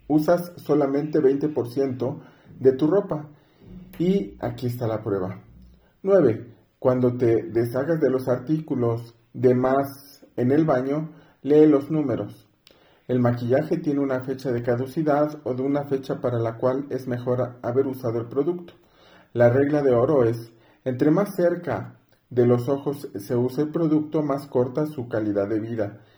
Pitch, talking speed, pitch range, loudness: 130 Hz, 155 wpm, 120-150 Hz, -23 LUFS